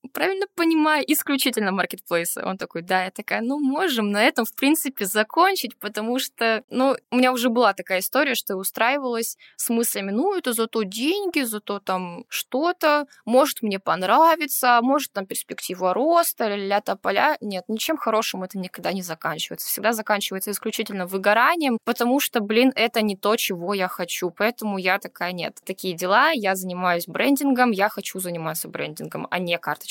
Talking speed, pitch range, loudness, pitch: 165 wpm, 190-265 Hz, -22 LUFS, 220 Hz